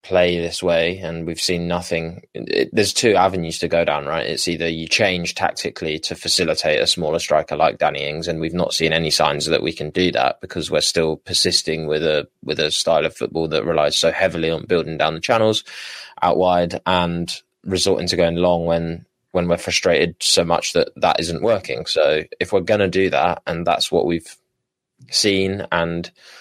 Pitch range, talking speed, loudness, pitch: 80-90 Hz, 200 wpm, -19 LUFS, 85 Hz